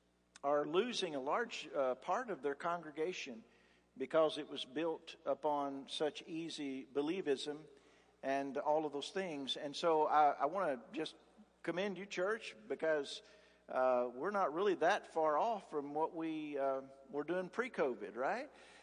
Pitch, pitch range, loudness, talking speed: 150 Hz, 140-170 Hz, -39 LUFS, 155 wpm